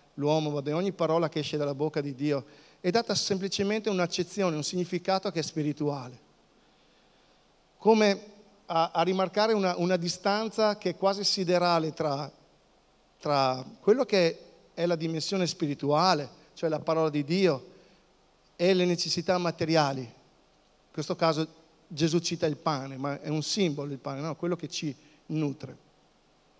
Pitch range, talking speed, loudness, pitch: 150-185 Hz, 150 wpm, -28 LUFS, 165 Hz